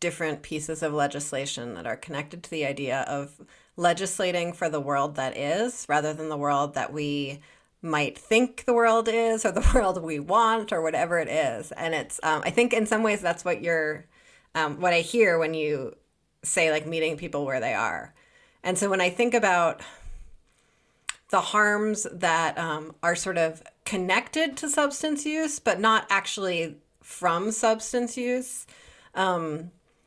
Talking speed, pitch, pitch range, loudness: 170 wpm, 170 Hz, 155-220 Hz, -26 LUFS